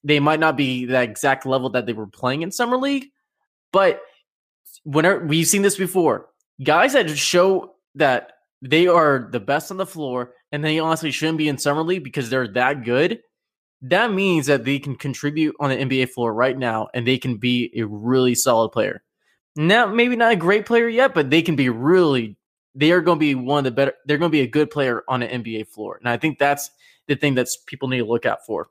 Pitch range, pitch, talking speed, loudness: 125-165 Hz, 145 Hz, 225 wpm, -20 LUFS